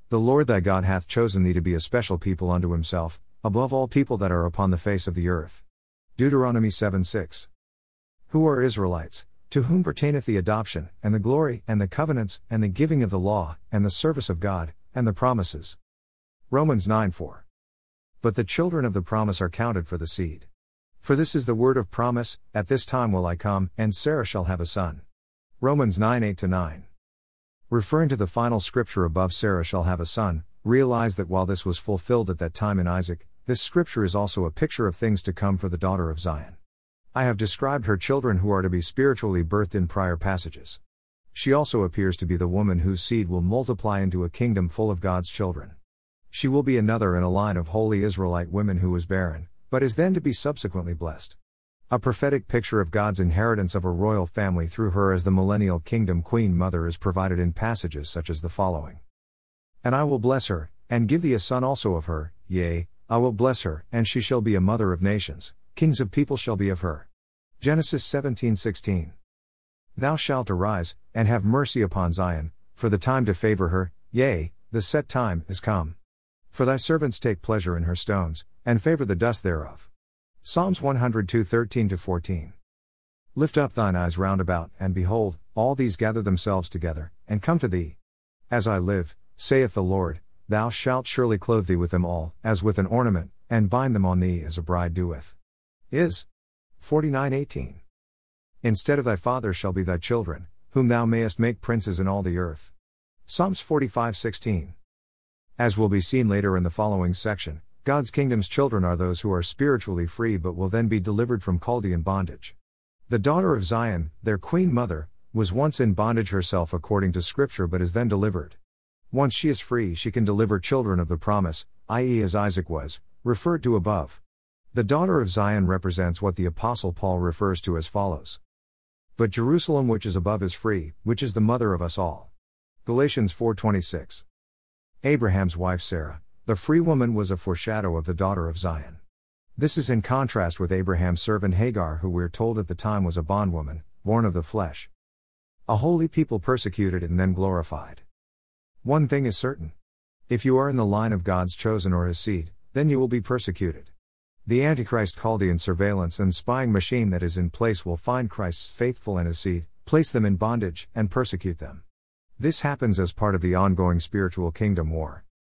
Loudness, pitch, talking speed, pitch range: -25 LUFS, 95 Hz, 195 wpm, 85-115 Hz